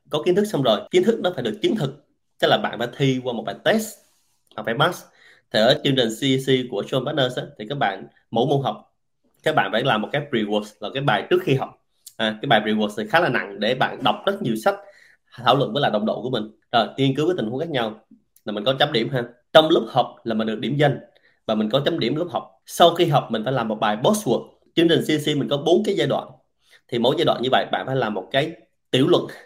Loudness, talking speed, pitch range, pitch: -21 LUFS, 270 wpm, 115-165 Hz, 135 Hz